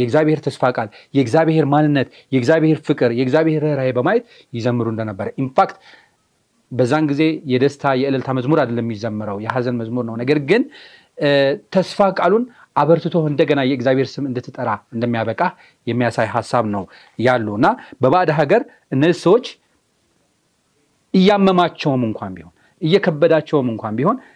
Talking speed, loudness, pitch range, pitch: 120 wpm, -18 LUFS, 120-160 Hz, 140 Hz